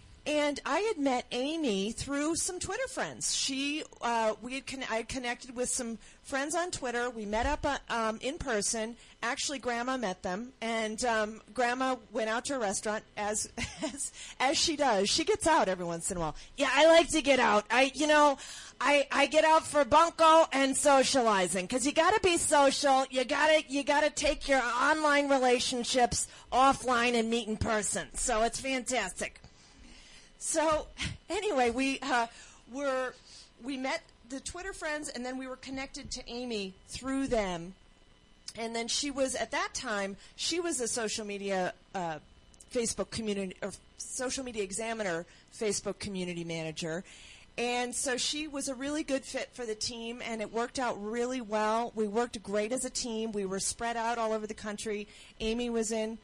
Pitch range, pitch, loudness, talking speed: 220-280 Hz, 245 Hz, -30 LUFS, 175 wpm